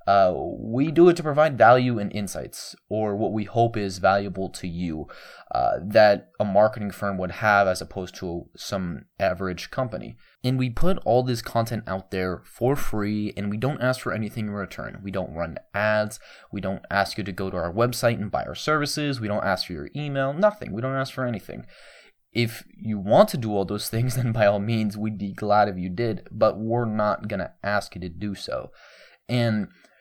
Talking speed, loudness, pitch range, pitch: 210 wpm, -24 LUFS, 100-120 Hz, 105 Hz